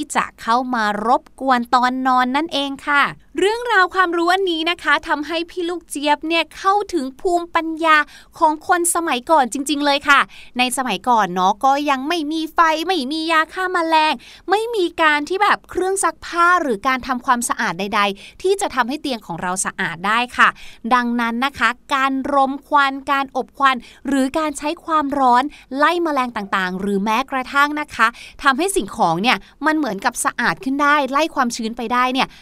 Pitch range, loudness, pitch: 250-320 Hz, -18 LUFS, 280 Hz